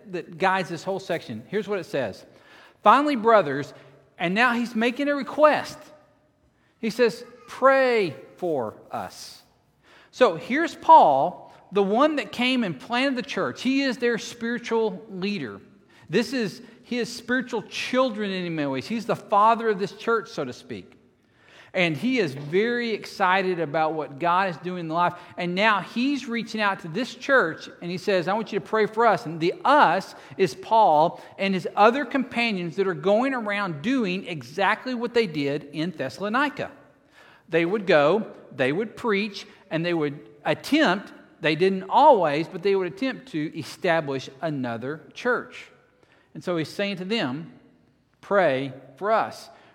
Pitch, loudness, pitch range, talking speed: 205 Hz, -24 LUFS, 175-235 Hz, 165 wpm